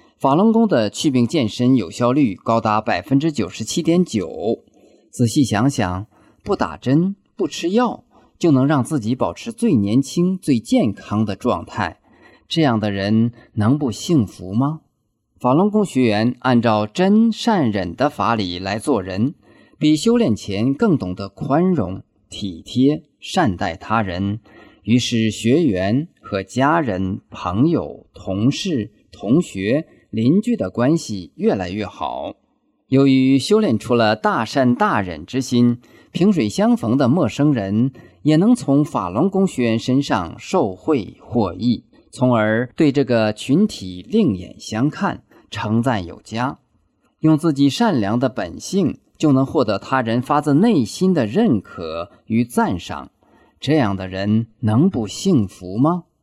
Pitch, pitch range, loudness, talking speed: 125 Hz, 105-155 Hz, -19 LUFS, 205 characters per minute